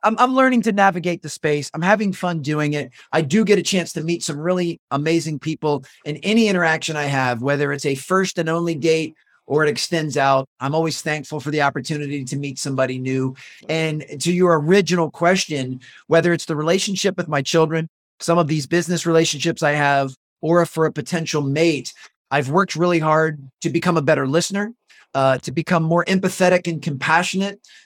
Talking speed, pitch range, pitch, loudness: 190 wpm, 145-175 Hz, 160 Hz, -20 LUFS